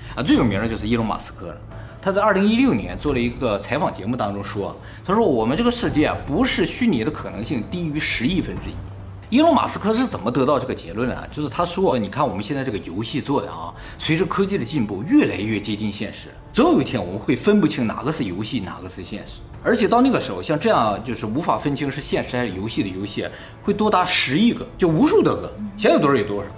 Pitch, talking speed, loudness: 125 Hz, 370 characters per minute, -20 LUFS